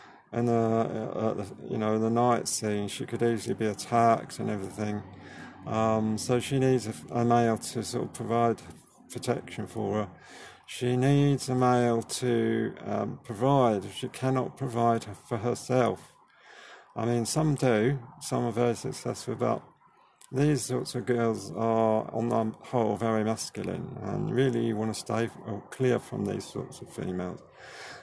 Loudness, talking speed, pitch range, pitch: -29 LUFS, 165 wpm, 110-125 Hz, 115 Hz